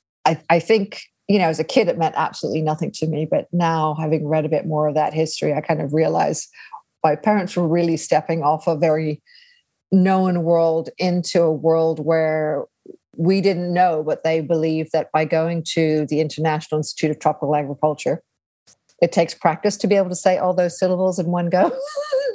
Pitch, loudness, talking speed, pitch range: 165 Hz, -20 LUFS, 190 wpm, 155-180 Hz